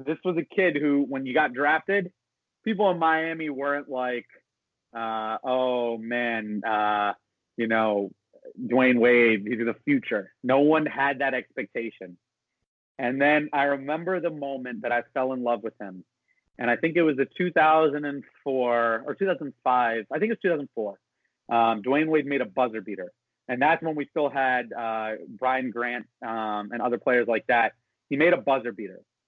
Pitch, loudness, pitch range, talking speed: 130 Hz, -25 LUFS, 115-150 Hz, 160 wpm